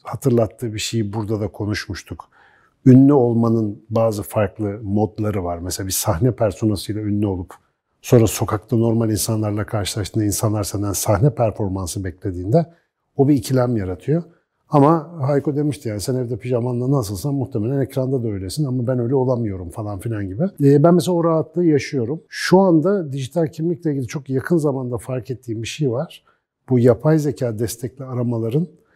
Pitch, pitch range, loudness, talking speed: 120 Hz, 105-140 Hz, -19 LUFS, 155 wpm